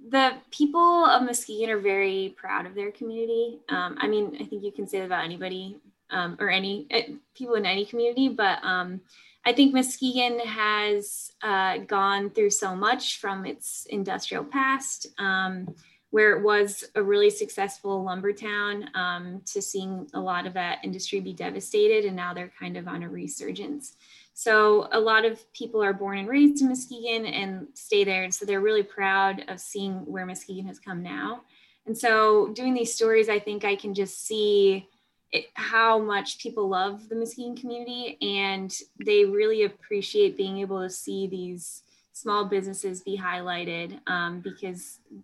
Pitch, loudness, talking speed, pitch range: 205 Hz, -26 LUFS, 175 wpm, 190-240 Hz